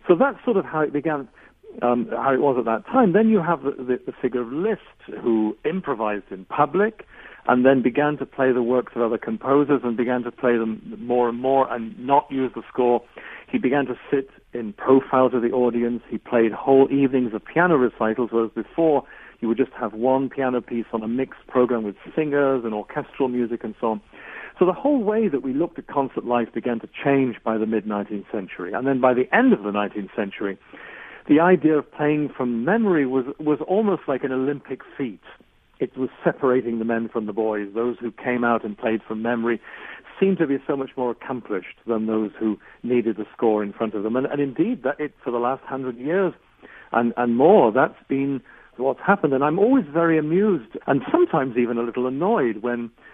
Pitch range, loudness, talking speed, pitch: 115-140 Hz, -22 LUFS, 215 wpm, 125 Hz